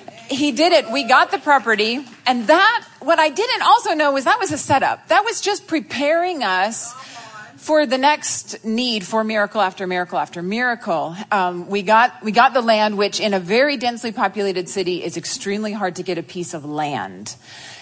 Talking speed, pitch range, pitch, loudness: 190 wpm, 200-295 Hz, 230 Hz, -18 LUFS